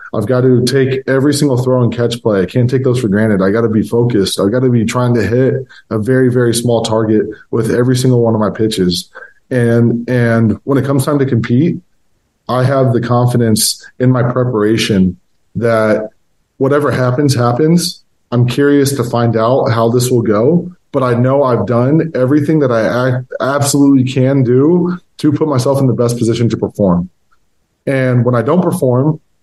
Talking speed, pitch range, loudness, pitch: 190 wpm, 115-135 Hz, -12 LUFS, 125 Hz